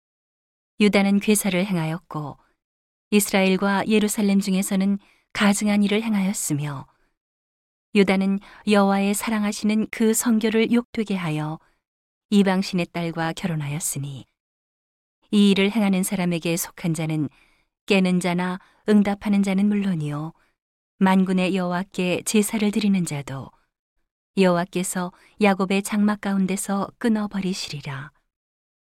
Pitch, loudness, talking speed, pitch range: 195 Hz, -22 LUFS, 270 characters per minute, 175-210 Hz